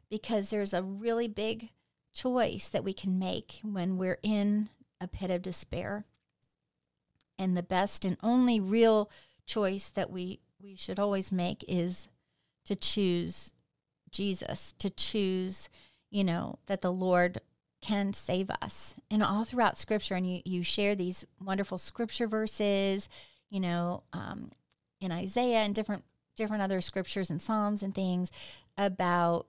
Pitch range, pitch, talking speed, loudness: 180-210 Hz, 195 Hz, 145 wpm, -32 LUFS